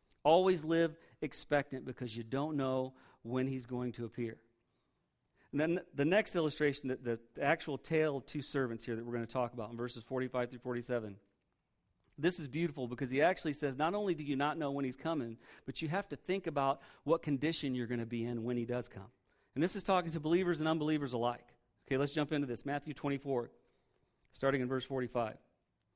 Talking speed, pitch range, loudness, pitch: 205 wpm, 120-155 Hz, -36 LUFS, 135 Hz